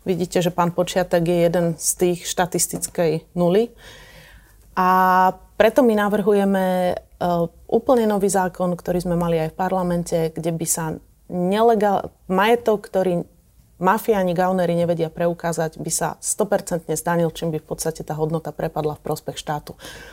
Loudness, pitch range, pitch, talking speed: -21 LUFS, 165-190 Hz, 180 Hz, 140 wpm